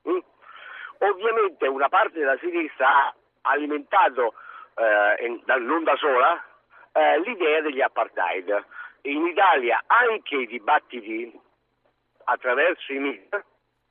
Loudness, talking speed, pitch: -23 LUFS, 110 wpm, 335 Hz